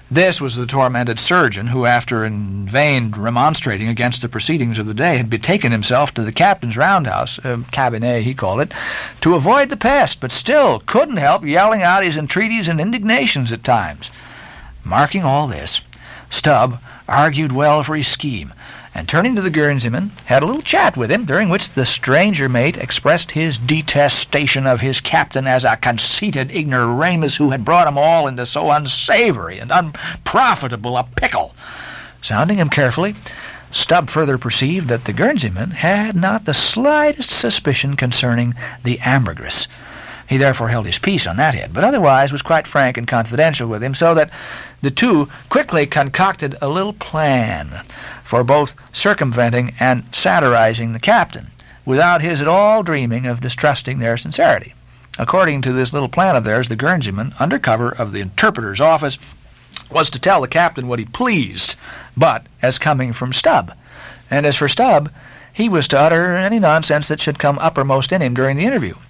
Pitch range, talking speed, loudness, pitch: 120-160 Hz, 170 wpm, -16 LUFS, 135 Hz